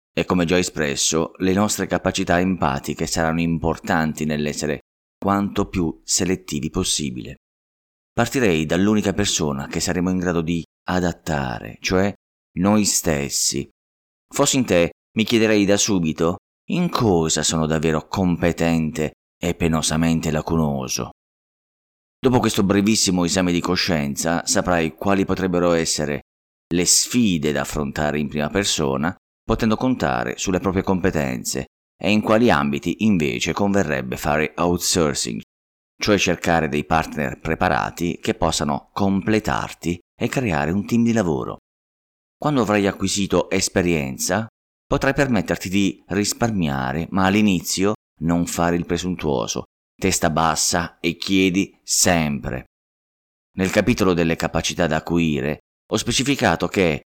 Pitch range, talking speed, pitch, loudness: 75-95 Hz, 120 wpm, 85 Hz, -20 LUFS